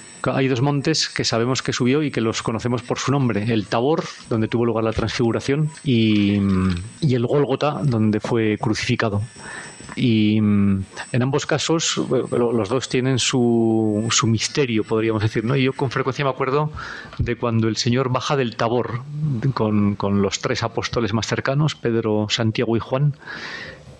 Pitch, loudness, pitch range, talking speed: 120 Hz, -20 LUFS, 110-135 Hz, 165 wpm